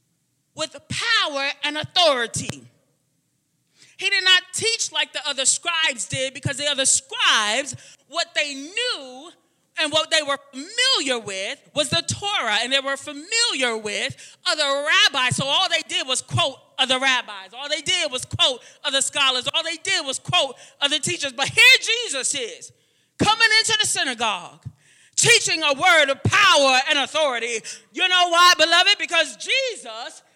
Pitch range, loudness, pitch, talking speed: 270-360 Hz, -19 LUFS, 300 Hz, 155 wpm